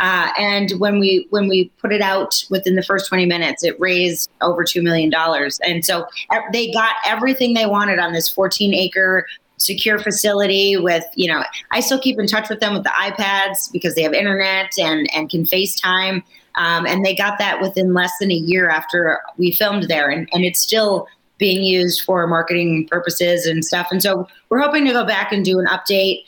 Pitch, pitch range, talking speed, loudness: 190 Hz, 175-200 Hz, 205 wpm, -17 LUFS